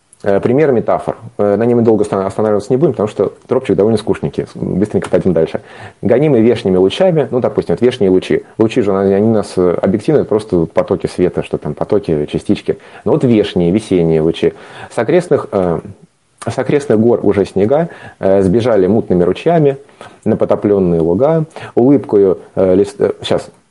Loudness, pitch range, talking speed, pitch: -13 LUFS, 95-130 Hz, 145 wpm, 105 Hz